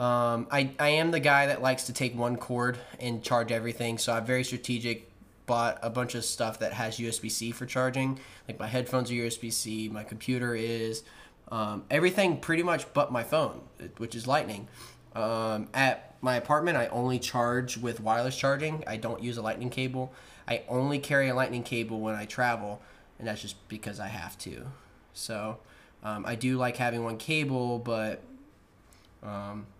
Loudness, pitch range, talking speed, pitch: -30 LUFS, 110-130 Hz, 180 wpm, 120 Hz